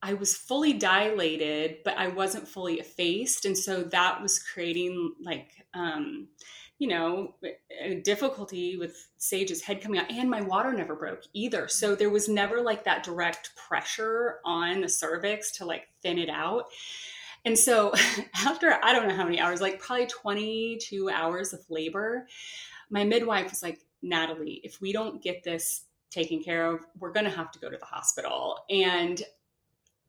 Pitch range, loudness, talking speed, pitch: 170-215 Hz, -28 LUFS, 170 wpm, 190 Hz